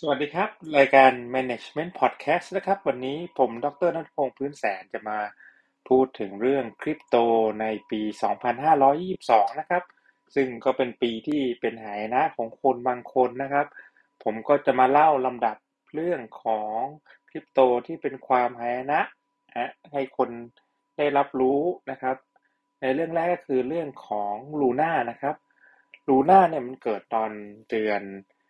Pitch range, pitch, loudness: 115-145 Hz, 130 Hz, -25 LUFS